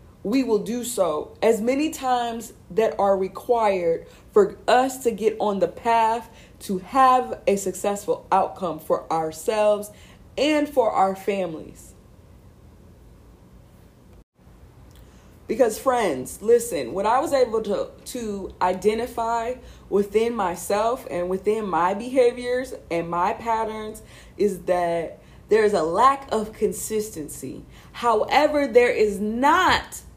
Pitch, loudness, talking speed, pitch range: 225 Hz, -23 LUFS, 115 wpm, 205-260 Hz